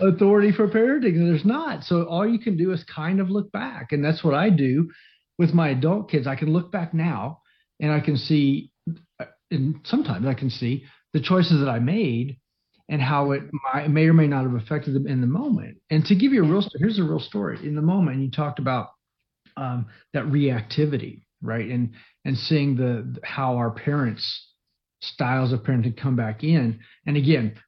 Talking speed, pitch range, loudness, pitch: 200 wpm, 130-170 Hz, -23 LUFS, 150 Hz